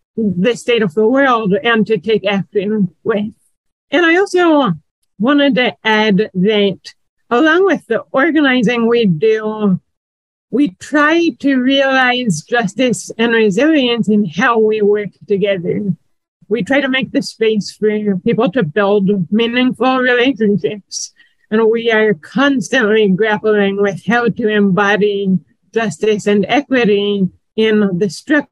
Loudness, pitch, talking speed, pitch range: -14 LUFS, 215 Hz, 130 wpm, 200-245 Hz